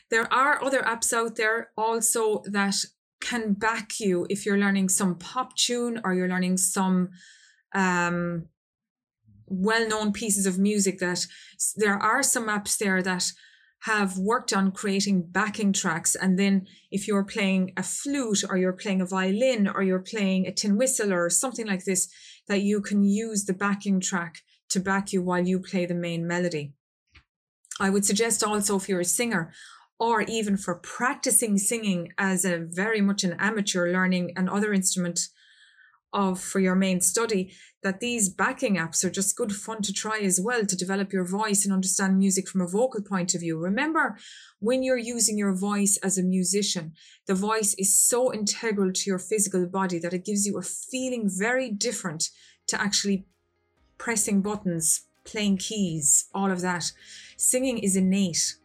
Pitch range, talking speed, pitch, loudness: 185-220 Hz, 170 wpm, 195 Hz, -25 LUFS